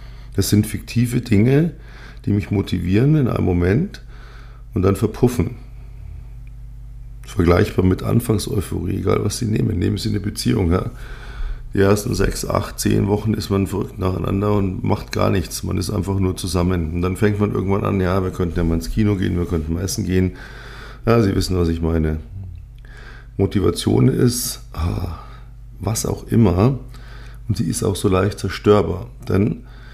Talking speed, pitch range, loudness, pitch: 165 wpm, 95-120 Hz, -19 LUFS, 105 Hz